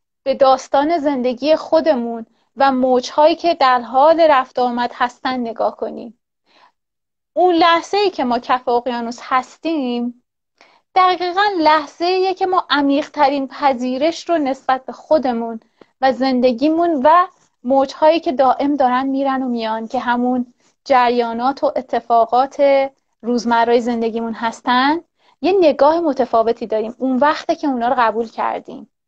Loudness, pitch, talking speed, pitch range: -16 LUFS, 265 Hz, 130 wpm, 245-310 Hz